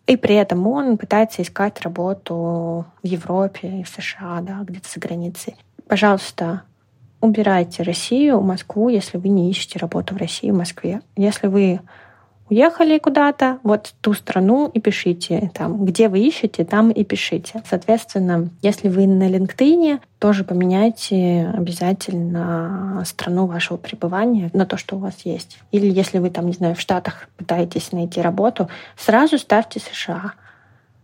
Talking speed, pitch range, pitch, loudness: 145 wpm, 175-215 Hz, 190 Hz, -19 LUFS